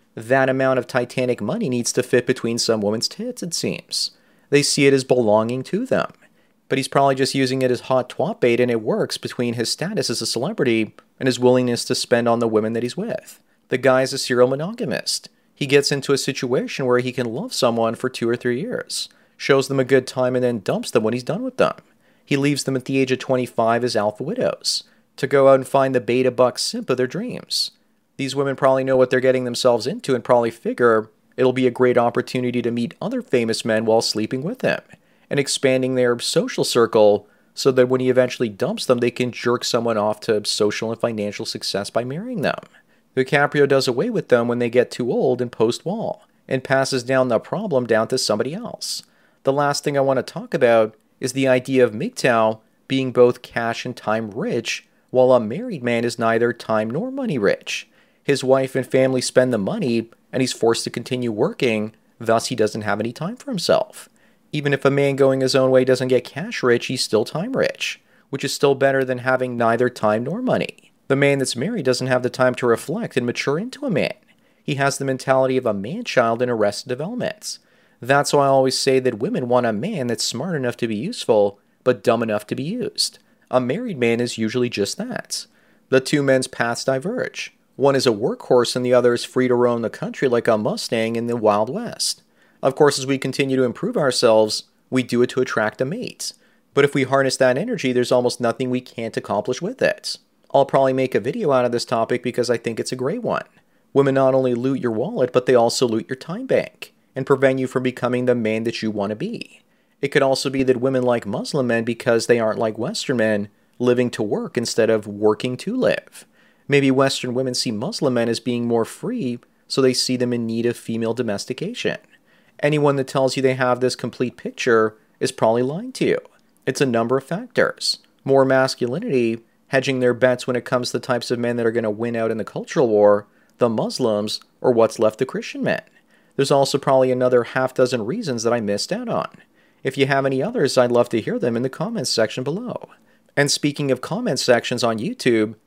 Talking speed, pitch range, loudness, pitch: 220 wpm, 120-135 Hz, -20 LUFS, 125 Hz